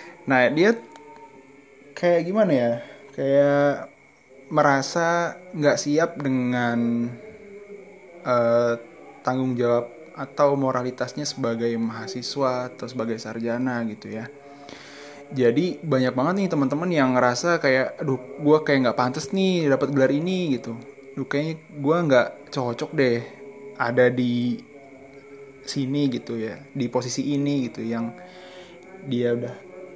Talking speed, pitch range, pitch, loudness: 115 wpm, 125-150 Hz, 135 Hz, -23 LUFS